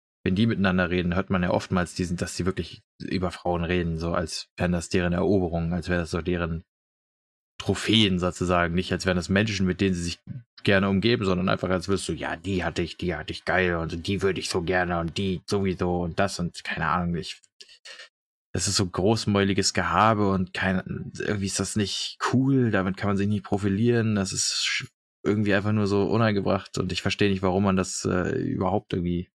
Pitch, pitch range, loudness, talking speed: 95 Hz, 90-100 Hz, -25 LUFS, 210 wpm